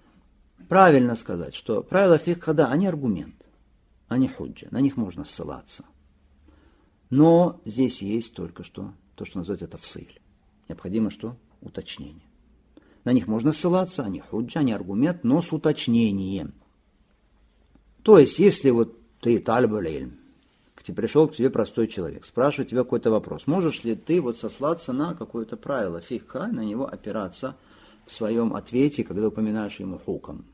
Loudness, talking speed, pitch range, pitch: -23 LUFS, 145 wpm, 105-145 Hz, 115 Hz